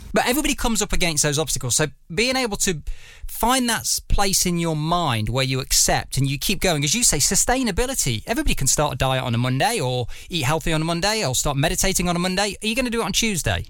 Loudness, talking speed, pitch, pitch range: -20 LUFS, 245 wpm, 170 Hz, 140-210 Hz